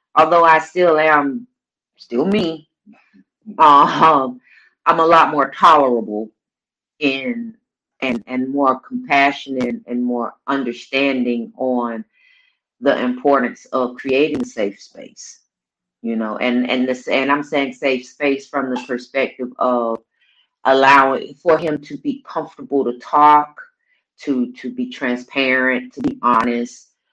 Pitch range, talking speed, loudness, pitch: 125-160 Hz, 125 wpm, -17 LUFS, 135 Hz